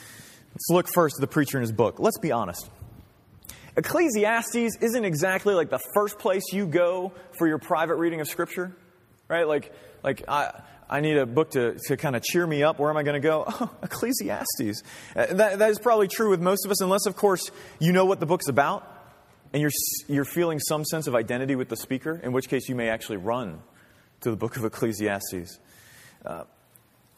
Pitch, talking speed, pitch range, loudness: 155 Hz, 205 wpm, 125-185 Hz, -25 LUFS